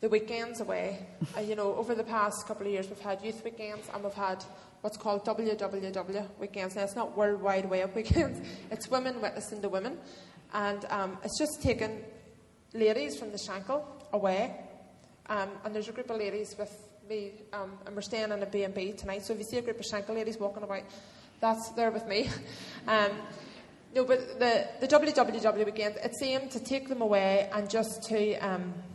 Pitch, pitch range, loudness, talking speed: 210 Hz, 200-225 Hz, -32 LUFS, 195 wpm